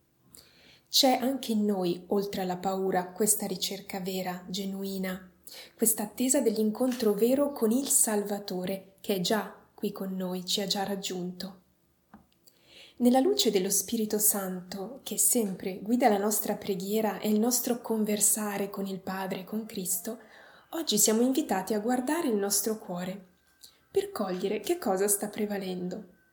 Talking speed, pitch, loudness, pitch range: 145 wpm, 205 Hz, -28 LUFS, 190-225 Hz